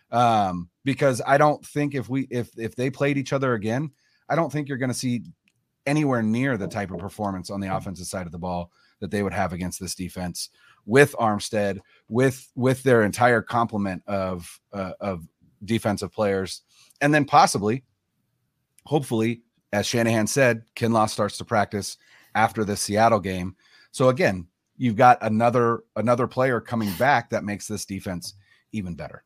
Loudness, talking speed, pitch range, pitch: -24 LUFS, 170 wpm, 100-130 Hz, 110 Hz